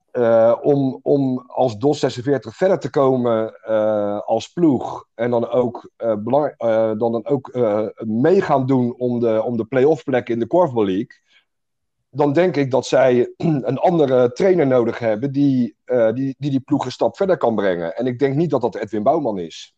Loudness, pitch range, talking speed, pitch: -19 LUFS, 115-140 Hz, 195 wpm, 125 Hz